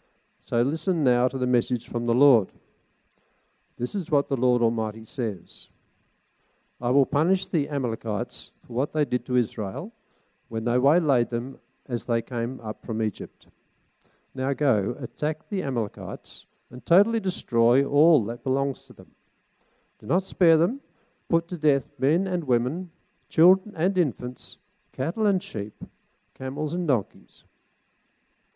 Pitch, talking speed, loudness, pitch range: 130 Hz, 145 wpm, -25 LUFS, 120-165 Hz